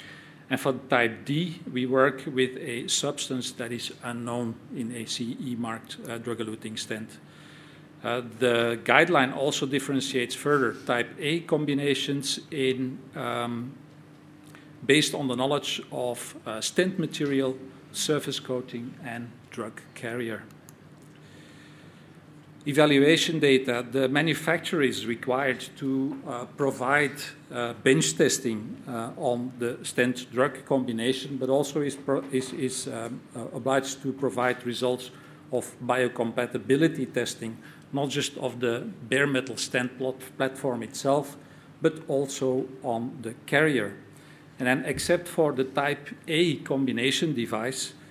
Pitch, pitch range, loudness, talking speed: 135 Hz, 125-145 Hz, -27 LUFS, 125 wpm